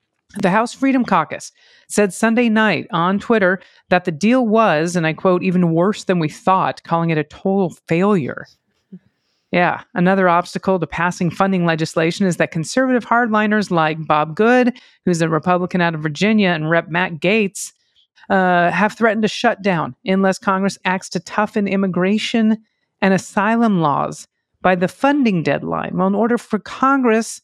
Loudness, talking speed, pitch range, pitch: -17 LUFS, 160 wpm, 175-215 Hz, 190 Hz